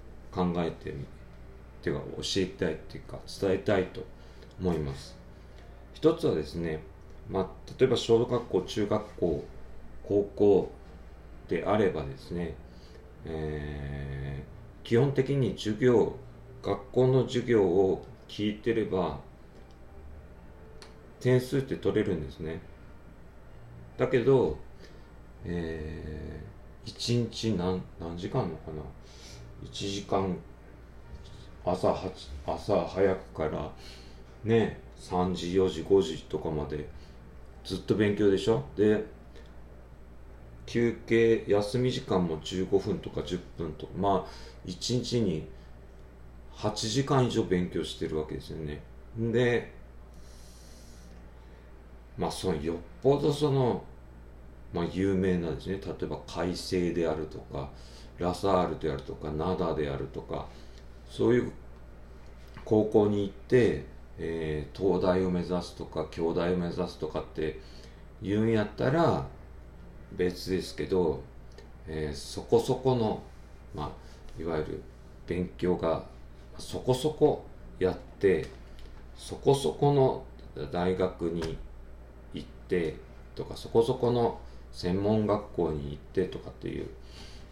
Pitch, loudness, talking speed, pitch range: 80 Hz, -30 LUFS, 195 characters per minute, 65-95 Hz